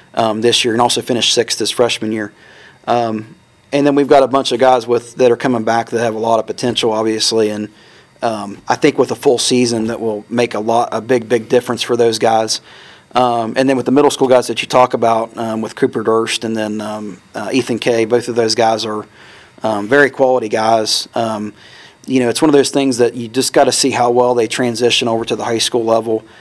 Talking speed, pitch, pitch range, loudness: 240 wpm, 115 Hz, 110-125 Hz, -14 LUFS